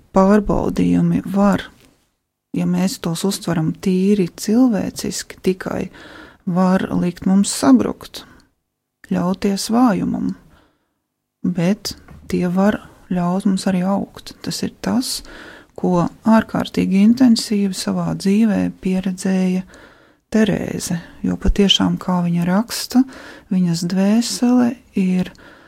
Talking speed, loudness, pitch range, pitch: 100 wpm, -18 LUFS, 180-220 Hz, 195 Hz